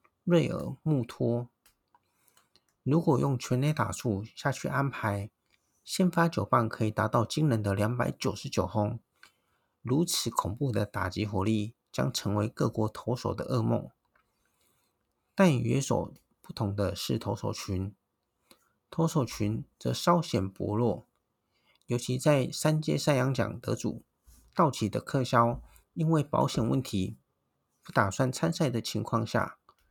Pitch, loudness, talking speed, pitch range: 120 Hz, -30 LUFS, 200 characters per minute, 105-150 Hz